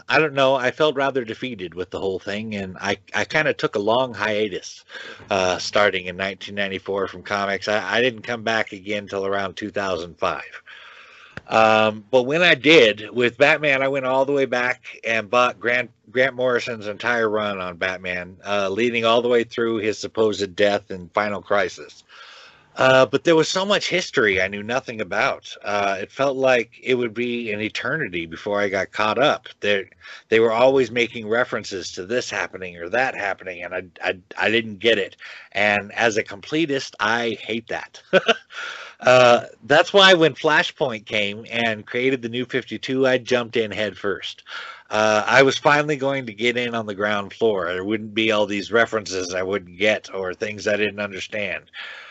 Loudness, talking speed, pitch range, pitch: -21 LUFS, 185 wpm, 100-125 Hz, 110 Hz